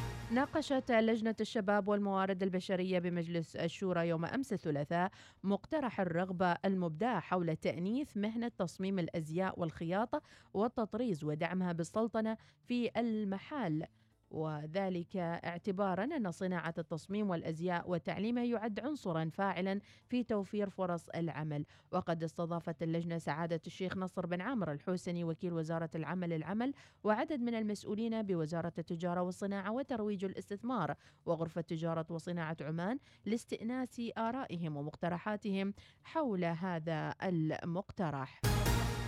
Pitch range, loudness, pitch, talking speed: 170-215 Hz, -37 LUFS, 185 Hz, 105 wpm